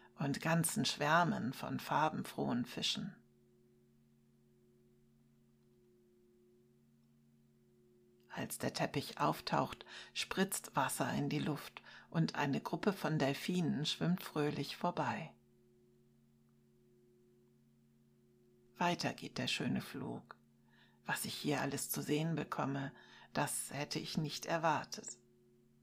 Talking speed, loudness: 95 wpm, -38 LUFS